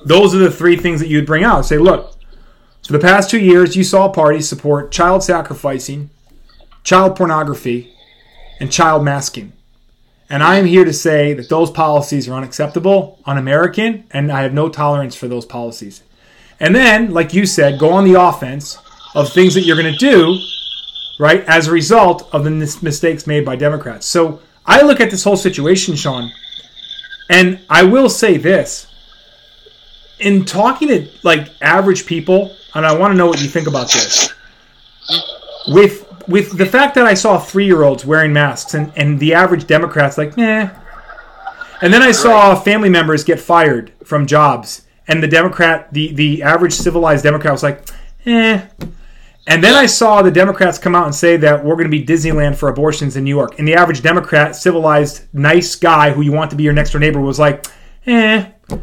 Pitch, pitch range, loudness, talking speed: 165 Hz, 145-185 Hz, -11 LUFS, 185 wpm